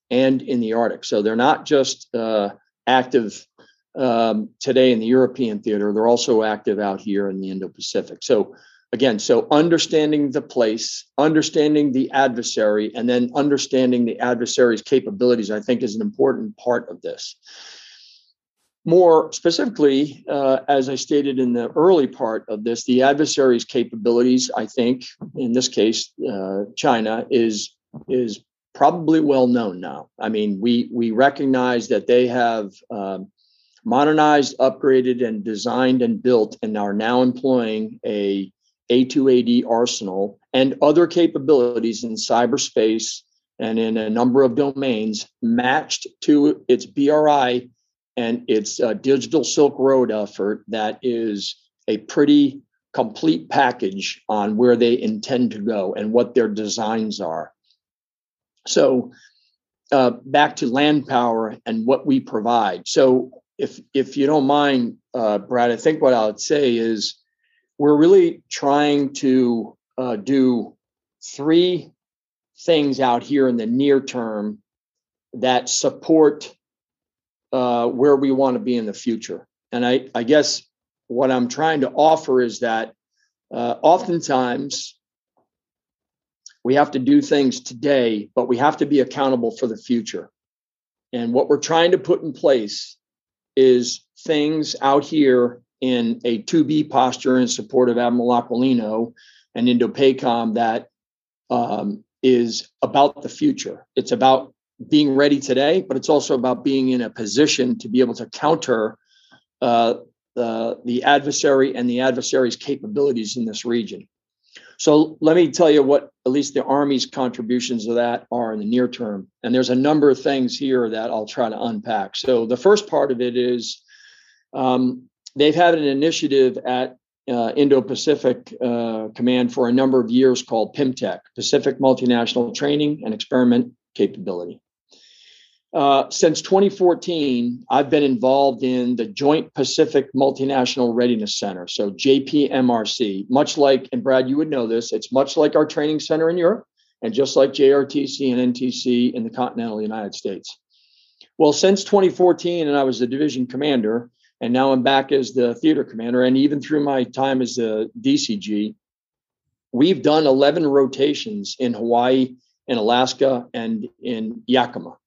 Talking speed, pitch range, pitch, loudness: 150 wpm, 120-145 Hz, 130 Hz, -19 LUFS